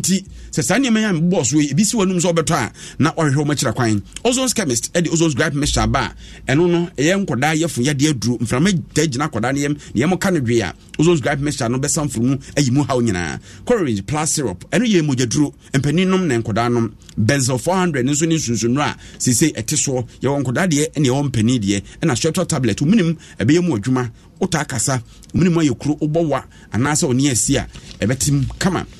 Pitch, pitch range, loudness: 145 Hz, 120-165 Hz, -18 LUFS